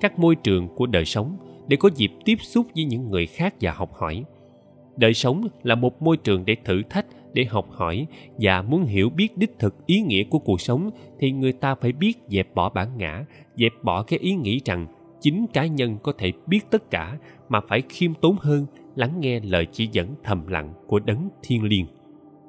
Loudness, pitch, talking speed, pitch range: -23 LUFS, 125 Hz, 215 wpm, 100-160 Hz